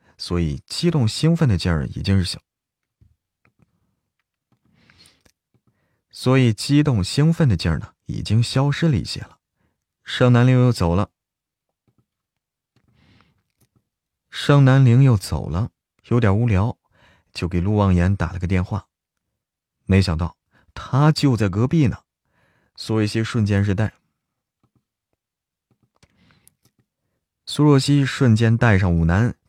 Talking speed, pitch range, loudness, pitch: 165 characters per minute, 95-130 Hz, -19 LUFS, 110 Hz